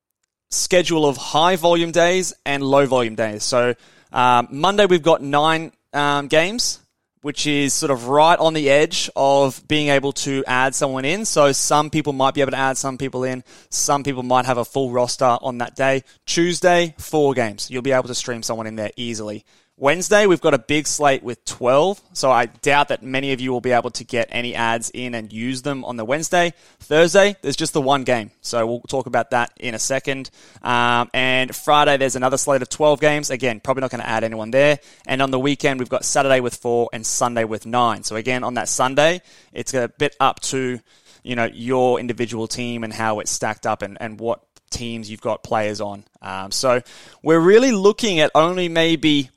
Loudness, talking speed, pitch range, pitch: -19 LUFS, 210 wpm, 120-145 Hz, 130 Hz